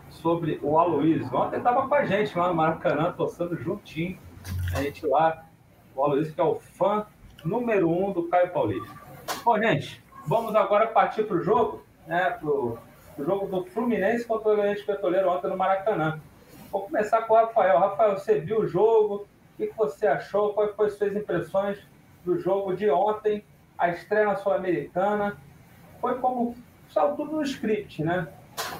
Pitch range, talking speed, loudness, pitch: 165-215 Hz, 170 wpm, -25 LUFS, 195 Hz